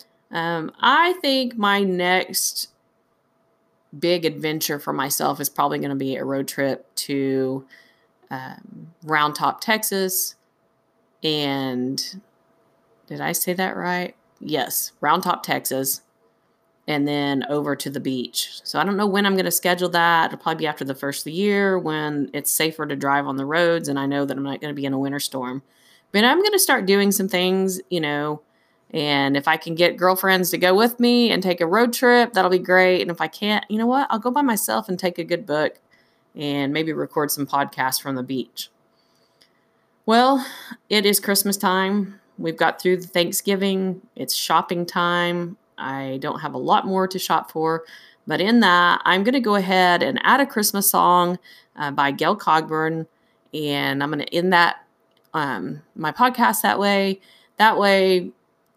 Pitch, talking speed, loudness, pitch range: 175 Hz, 185 wpm, -20 LUFS, 145-195 Hz